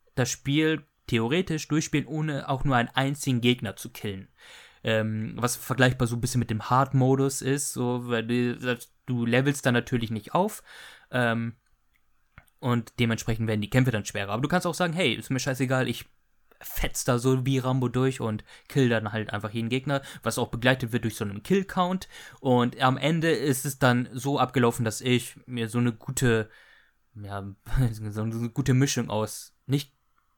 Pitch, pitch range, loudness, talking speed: 125 Hz, 115-135 Hz, -27 LUFS, 180 wpm